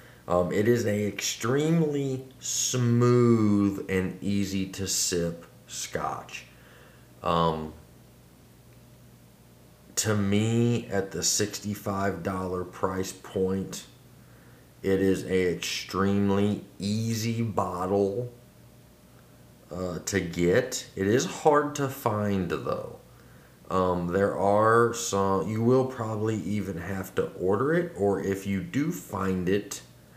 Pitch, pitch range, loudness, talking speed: 100 Hz, 90-110 Hz, -27 LUFS, 105 wpm